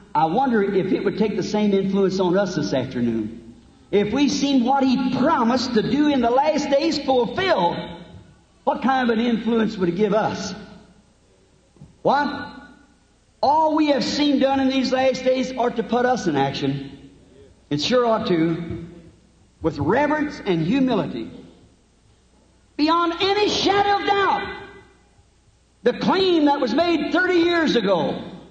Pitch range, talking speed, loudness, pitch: 200-290 Hz, 150 wpm, -20 LUFS, 255 Hz